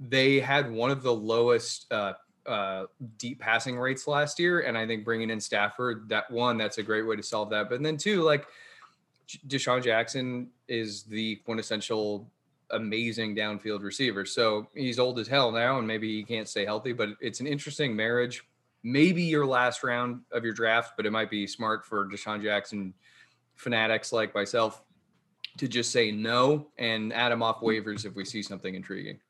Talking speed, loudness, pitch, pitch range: 180 wpm, -28 LUFS, 115 Hz, 110-125 Hz